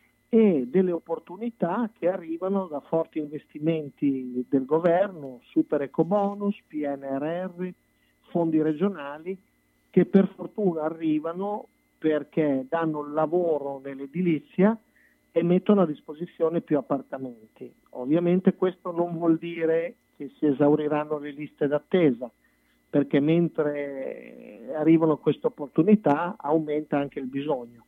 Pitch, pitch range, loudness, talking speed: 160 Hz, 145-180 Hz, -26 LUFS, 110 wpm